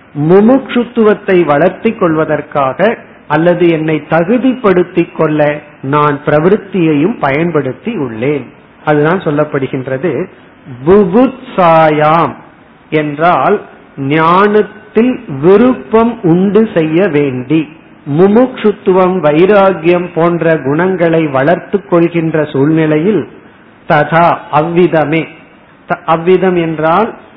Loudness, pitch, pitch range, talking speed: -10 LUFS, 170 Hz, 150-195 Hz, 65 wpm